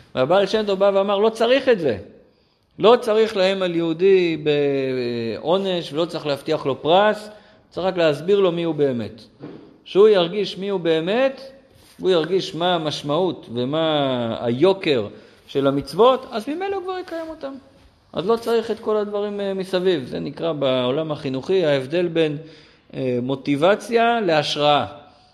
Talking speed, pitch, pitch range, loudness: 140 wpm, 175 Hz, 145-210 Hz, -20 LUFS